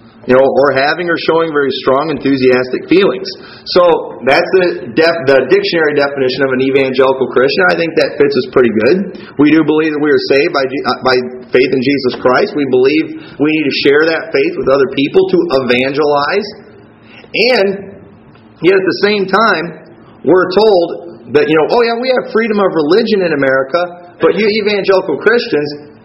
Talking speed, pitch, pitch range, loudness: 180 wpm, 165 Hz, 135-220 Hz, -11 LUFS